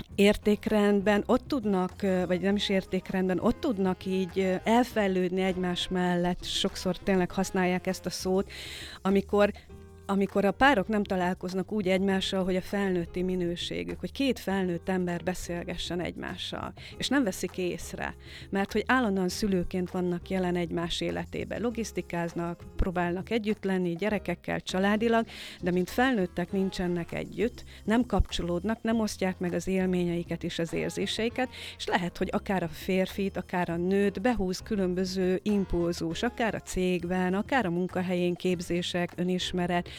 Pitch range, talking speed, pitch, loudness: 180-200 Hz, 135 wpm, 185 Hz, -29 LUFS